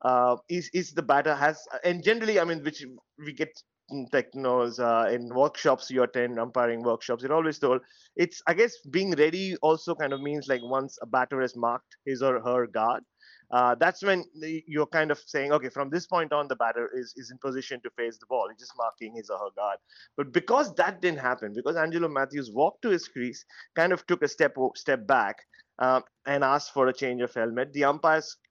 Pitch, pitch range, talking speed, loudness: 140 Hz, 125-160 Hz, 215 wpm, -27 LUFS